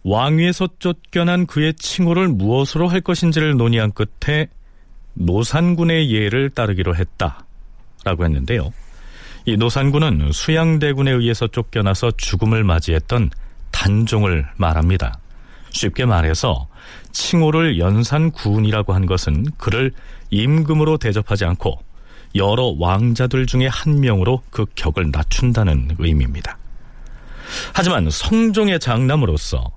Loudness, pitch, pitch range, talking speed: -18 LUFS, 115 Hz, 95-150 Hz, 280 characters per minute